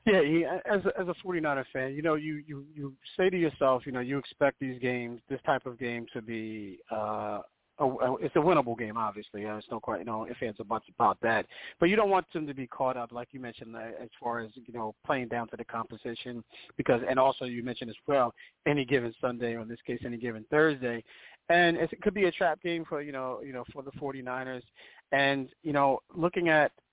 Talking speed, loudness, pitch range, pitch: 240 wpm, -30 LUFS, 120-150 Hz, 130 Hz